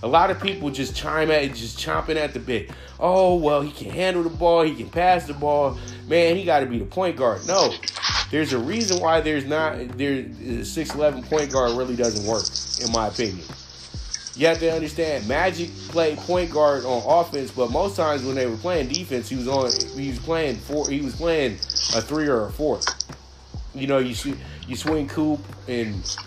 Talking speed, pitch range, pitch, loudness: 210 wpm, 120-160 Hz, 140 Hz, -23 LUFS